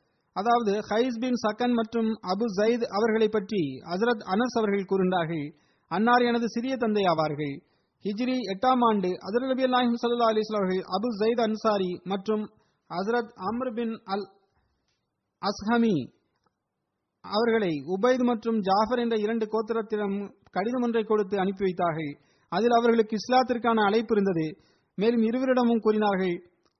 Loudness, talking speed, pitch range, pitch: -26 LUFS, 110 wpm, 195-235 Hz, 220 Hz